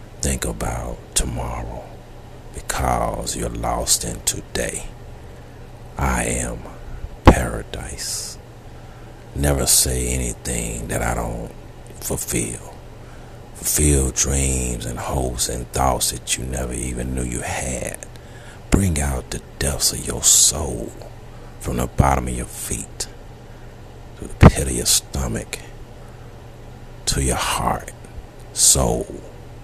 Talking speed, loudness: 110 wpm, -20 LUFS